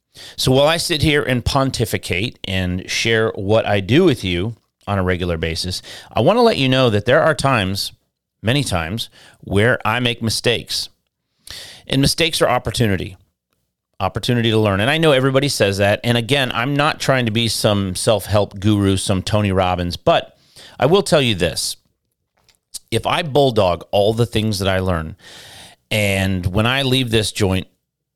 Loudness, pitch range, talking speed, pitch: -17 LUFS, 95-130 Hz, 175 wpm, 110 Hz